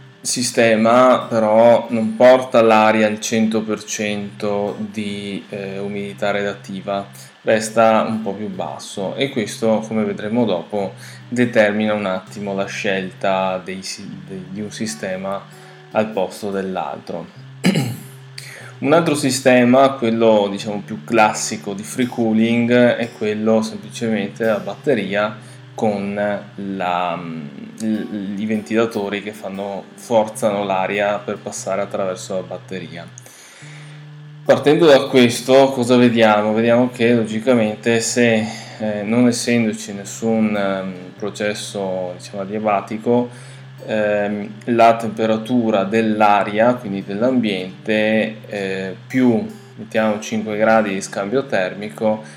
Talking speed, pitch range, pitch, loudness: 105 wpm, 100-120 Hz, 110 Hz, -18 LUFS